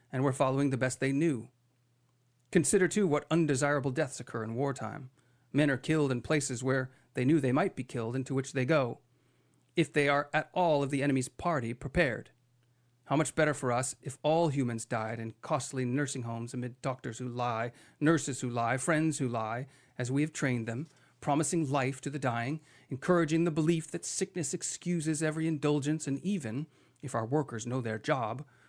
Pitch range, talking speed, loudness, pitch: 125-155 Hz, 190 wpm, -32 LUFS, 135 Hz